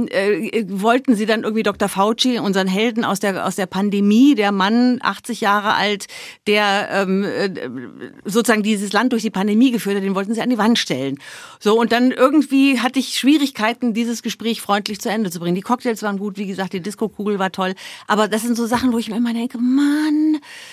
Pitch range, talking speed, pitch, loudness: 200-245 Hz, 205 wpm, 220 Hz, -18 LUFS